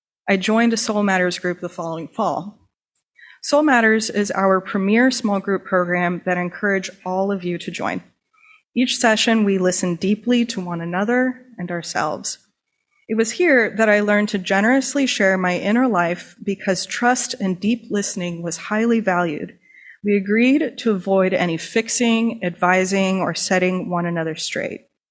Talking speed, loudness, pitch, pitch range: 160 wpm, -19 LUFS, 200 Hz, 180-230 Hz